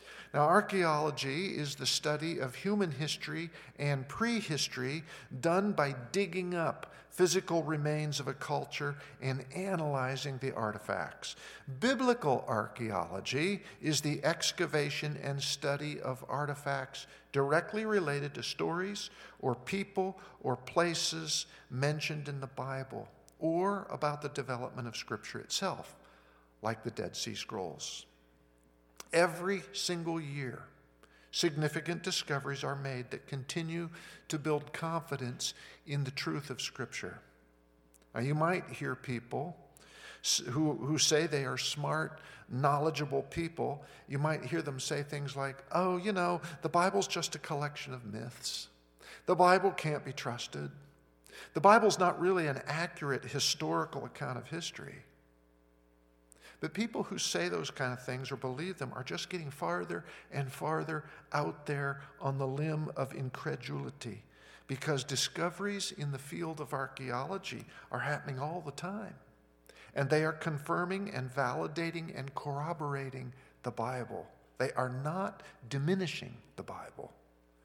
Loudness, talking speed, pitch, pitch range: -35 LUFS, 130 wpm, 145 Hz, 130-170 Hz